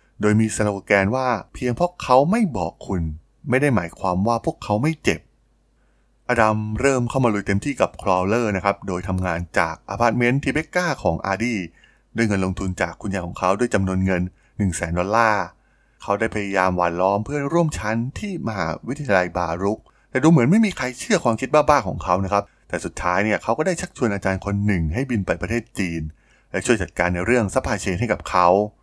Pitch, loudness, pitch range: 105 Hz, -21 LUFS, 95-125 Hz